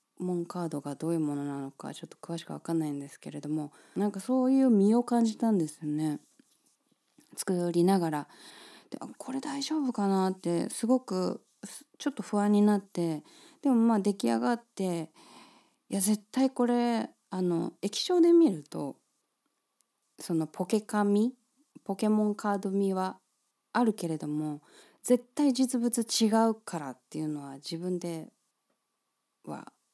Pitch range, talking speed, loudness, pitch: 165-240 Hz, 285 characters per minute, -29 LUFS, 200 Hz